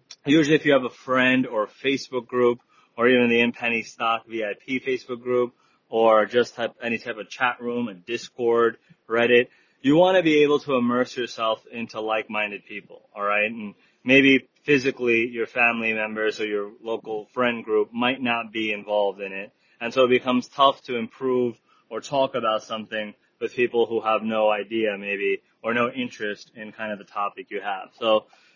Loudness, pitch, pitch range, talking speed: -23 LUFS, 115 Hz, 110-125 Hz, 185 wpm